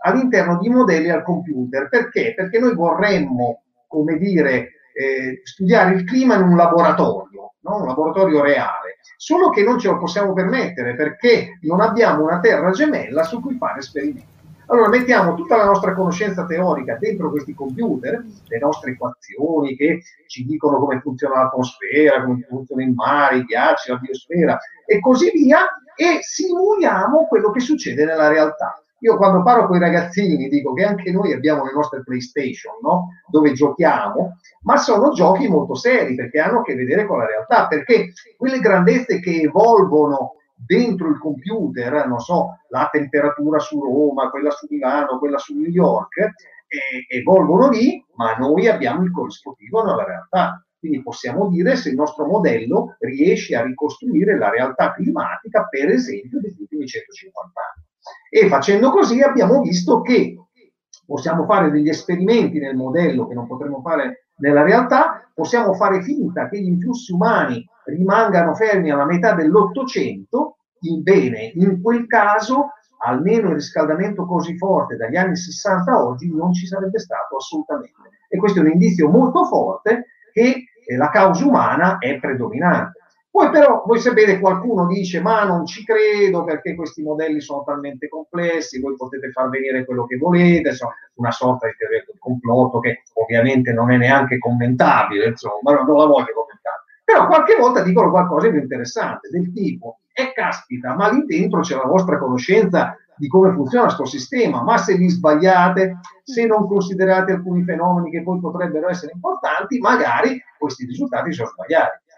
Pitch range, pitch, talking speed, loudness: 150-230 Hz, 180 Hz, 160 wpm, -17 LUFS